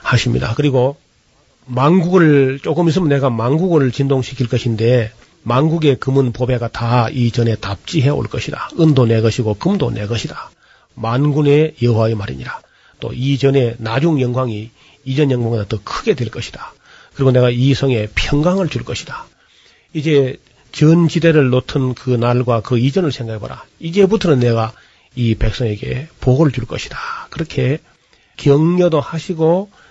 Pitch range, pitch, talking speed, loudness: 120-150 Hz, 130 Hz, 305 characters per minute, -16 LUFS